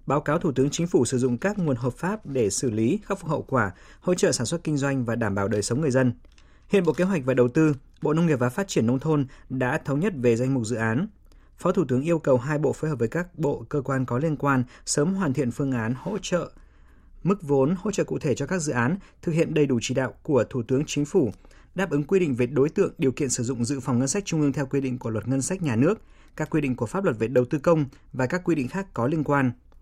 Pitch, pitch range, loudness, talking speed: 140 Hz, 125-160 Hz, -25 LUFS, 290 wpm